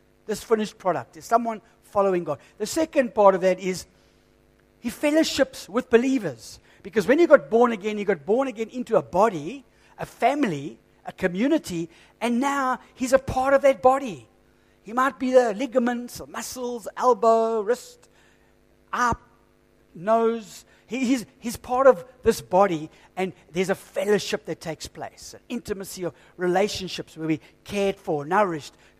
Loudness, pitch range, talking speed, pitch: -24 LUFS, 180-255 Hz, 155 wpm, 215 Hz